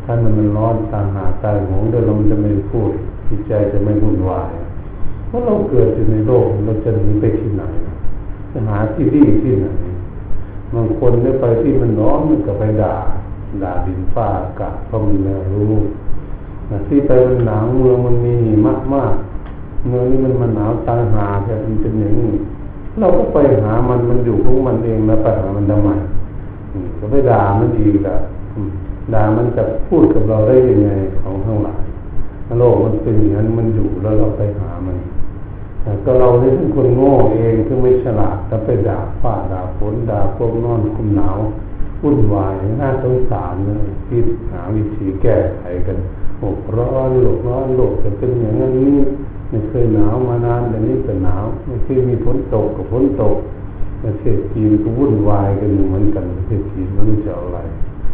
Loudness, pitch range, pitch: -16 LUFS, 100-115 Hz, 105 Hz